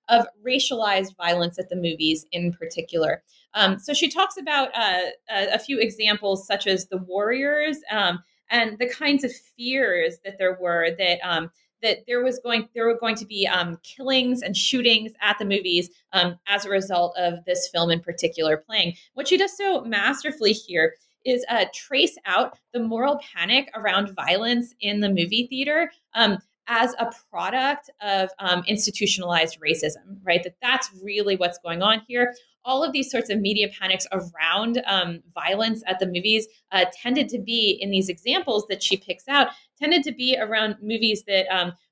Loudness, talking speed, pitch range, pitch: -23 LUFS, 180 wpm, 180-245 Hz, 205 Hz